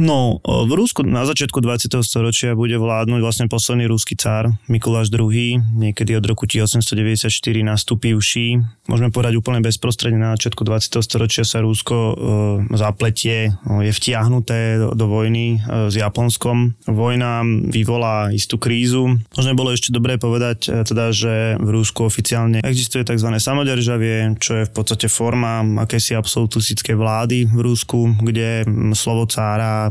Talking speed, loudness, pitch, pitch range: 140 wpm, -17 LUFS, 115 Hz, 110-120 Hz